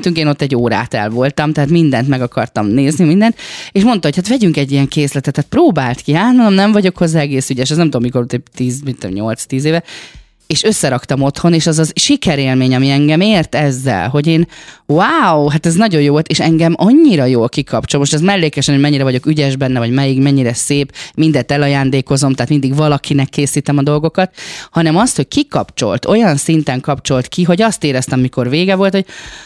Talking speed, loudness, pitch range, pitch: 200 wpm, -12 LUFS, 135-165 Hz, 145 Hz